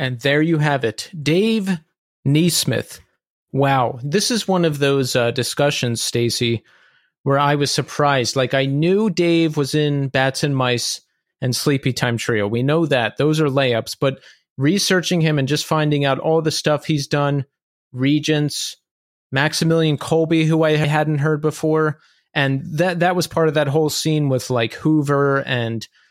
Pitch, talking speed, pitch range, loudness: 145 Hz, 160 wpm, 135-160 Hz, -19 LUFS